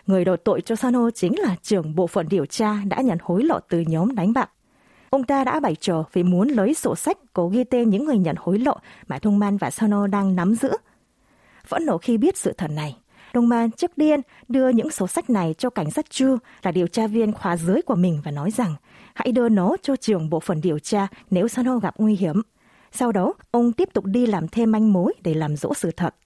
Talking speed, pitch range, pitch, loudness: 240 wpm, 180-245 Hz, 210 Hz, -22 LUFS